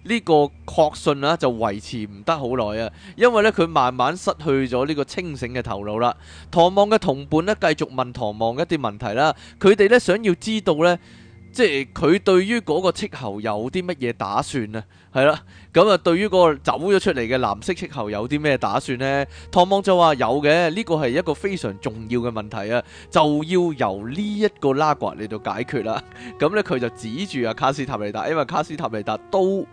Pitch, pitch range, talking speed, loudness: 145 Hz, 120-180 Hz, 295 characters per minute, -21 LUFS